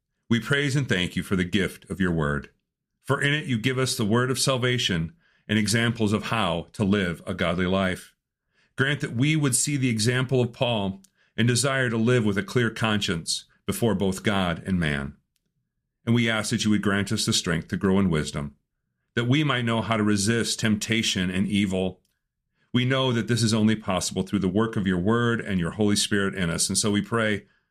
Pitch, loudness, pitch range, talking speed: 110 Hz, -24 LUFS, 95-120 Hz, 215 wpm